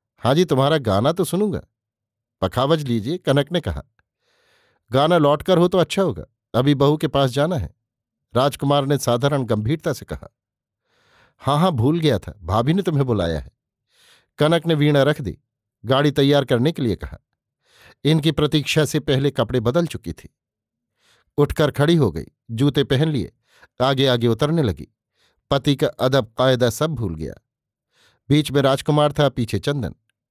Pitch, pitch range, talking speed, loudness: 140 Hz, 115-150 Hz, 160 wpm, -20 LUFS